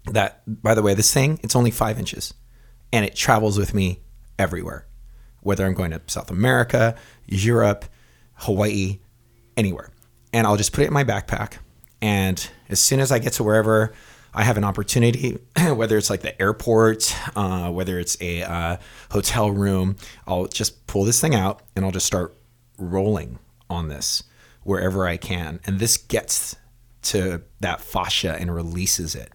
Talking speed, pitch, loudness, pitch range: 170 wpm, 100 Hz, -21 LUFS, 95-115 Hz